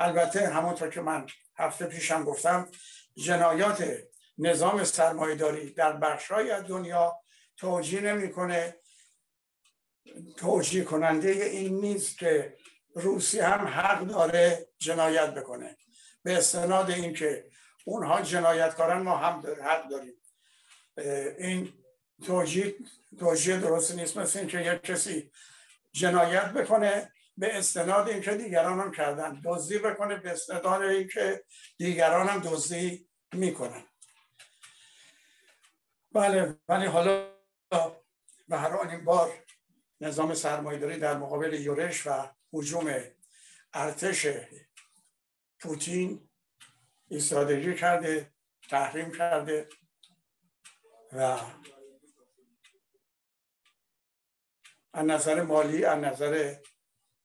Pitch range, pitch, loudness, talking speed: 155-195 Hz, 170 Hz, -28 LUFS, 95 wpm